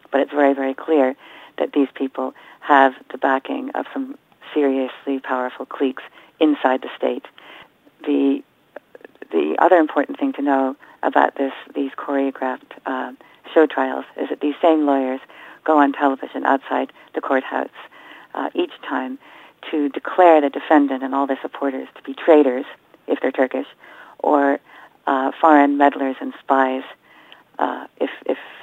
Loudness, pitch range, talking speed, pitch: -20 LUFS, 135-155 Hz, 145 wpm, 140 Hz